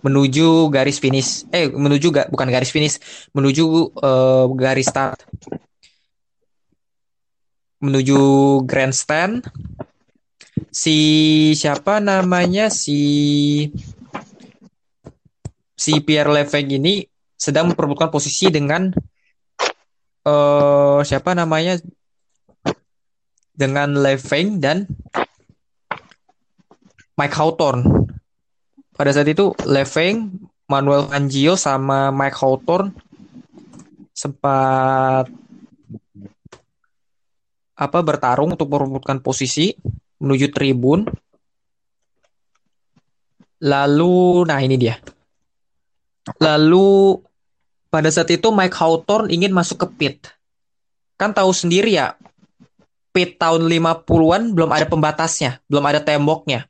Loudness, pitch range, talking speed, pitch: -16 LUFS, 135-170 Hz, 85 wpm, 150 Hz